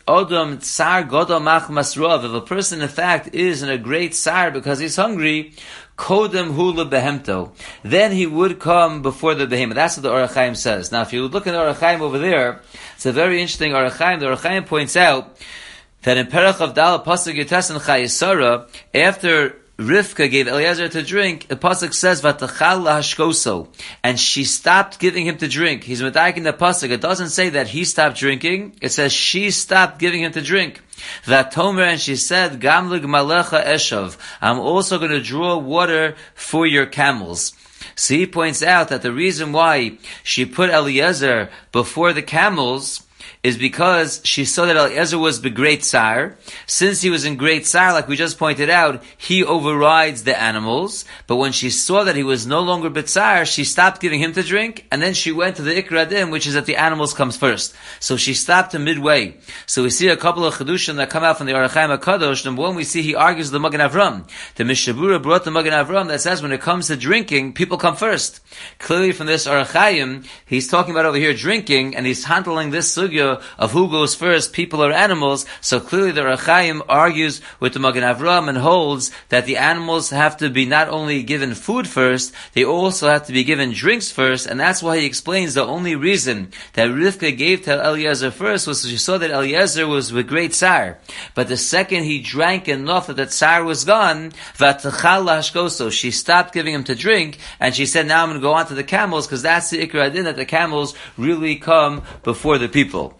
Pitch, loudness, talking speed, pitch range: 155 Hz, -17 LUFS, 200 wpm, 140-175 Hz